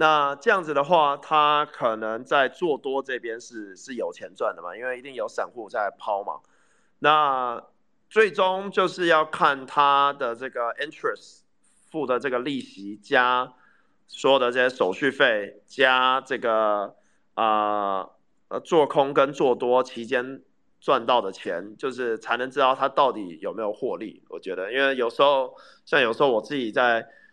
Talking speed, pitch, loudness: 245 characters per minute, 140 Hz, -23 LUFS